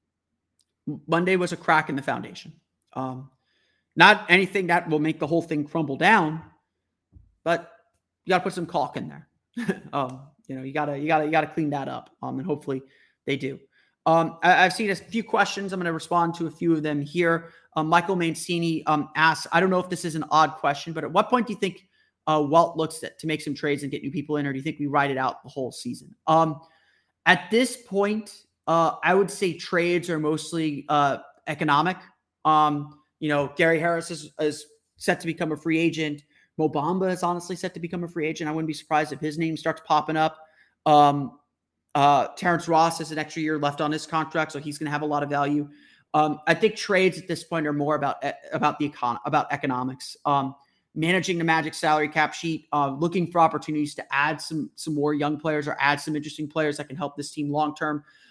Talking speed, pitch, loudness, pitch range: 225 wpm, 155 Hz, -24 LUFS, 145-170 Hz